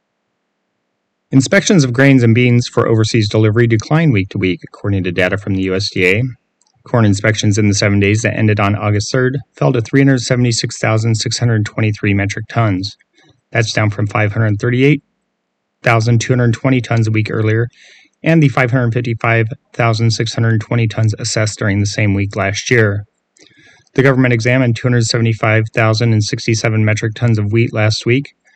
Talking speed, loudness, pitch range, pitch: 130 wpm, -14 LUFS, 105-125 Hz, 115 Hz